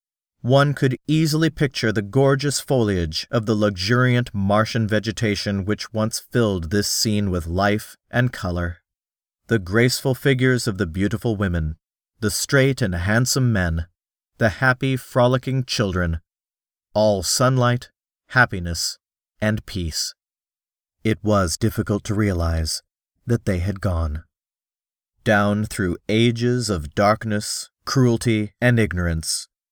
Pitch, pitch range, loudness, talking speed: 105 Hz, 95-120 Hz, -21 LUFS, 120 wpm